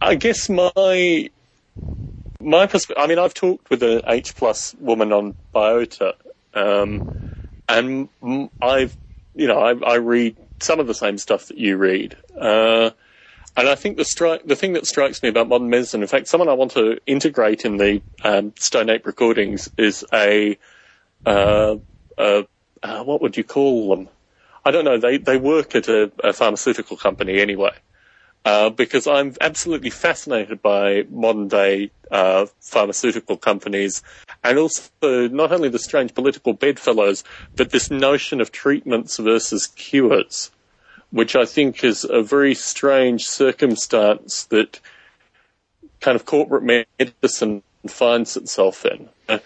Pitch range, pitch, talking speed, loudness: 105-140 Hz, 115 Hz, 150 wpm, -18 LUFS